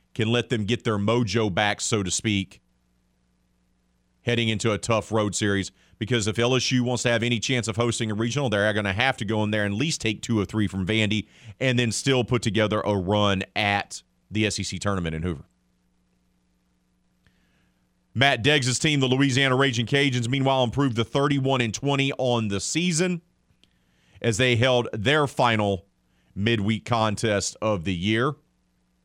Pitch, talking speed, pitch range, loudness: 110 Hz, 175 wpm, 95-125 Hz, -24 LUFS